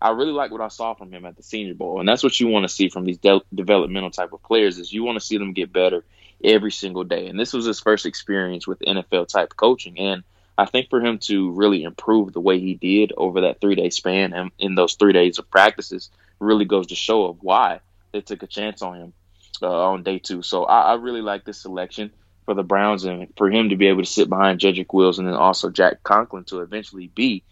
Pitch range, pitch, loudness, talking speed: 90-105 Hz, 95 Hz, -20 LUFS, 255 wpm